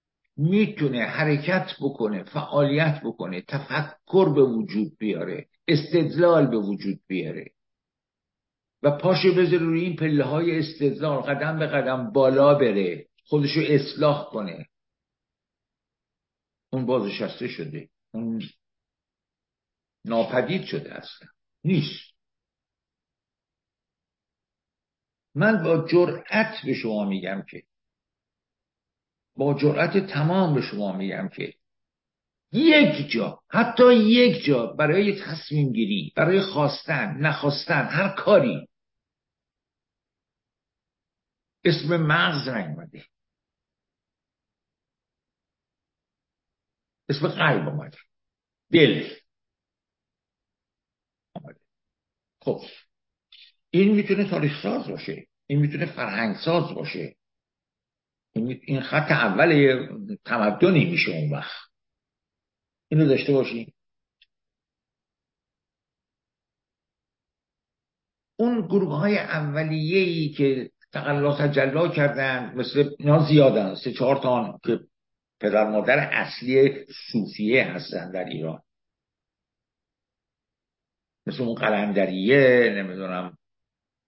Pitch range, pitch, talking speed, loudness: 125-170 Hz, 145 Hz, 85 wpm, -23 LUFS